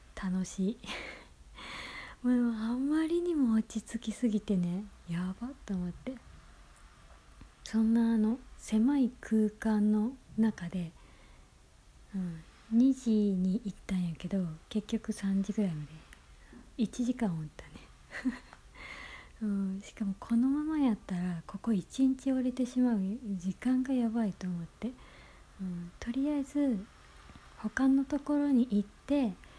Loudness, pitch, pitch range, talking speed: -32 LUFS, 220 Hz, 190-250 Hz, 225 characters per minute